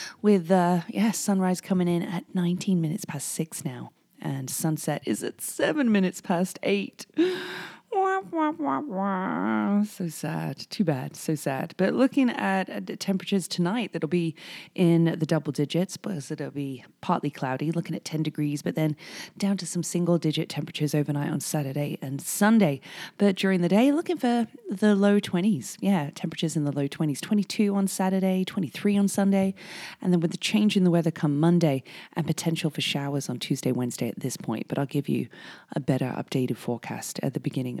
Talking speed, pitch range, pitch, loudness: 180 wpm, 150-195 Hz, 175 Hz, -26 LUFS